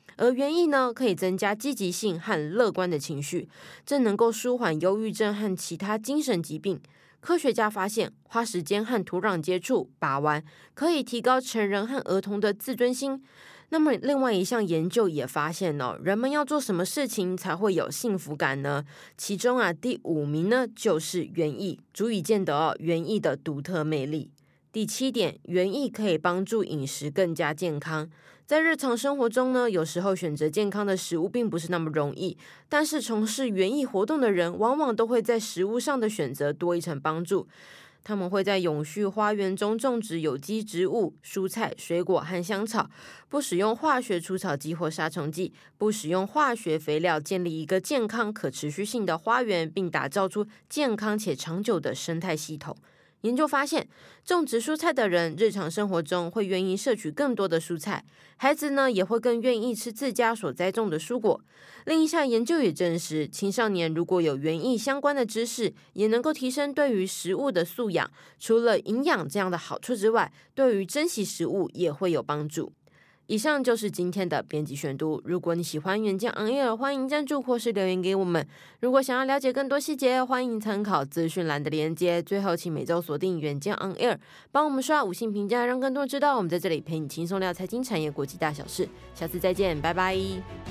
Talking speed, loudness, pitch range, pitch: 295 characters per minute, -27 LUFS, 170-240 Hz, 195 Hz